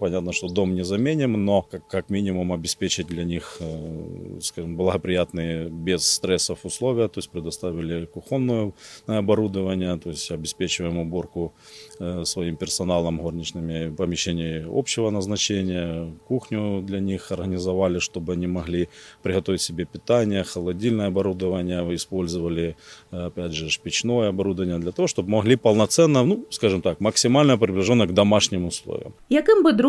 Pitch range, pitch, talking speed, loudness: 85-105 Hz, 90 Hz, 120 wpm, -23 LUFS